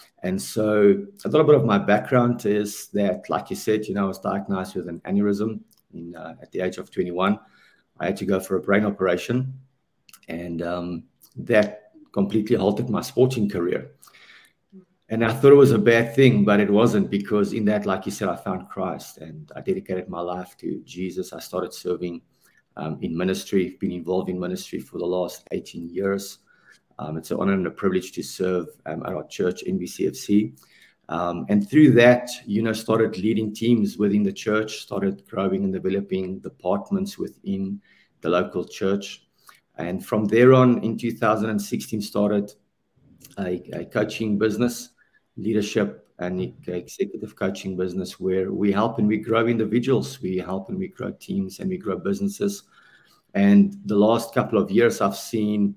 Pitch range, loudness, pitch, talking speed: 95-125 Hz, -23 LUFS, 105 Hz, 175 wpm